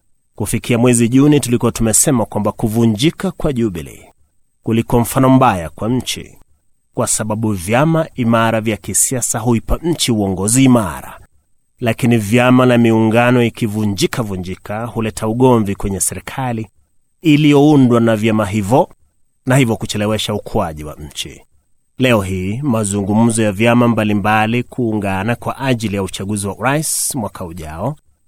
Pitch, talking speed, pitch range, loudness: 115 Hz, 130 wpm, 105-125 Hz, -15 LUFS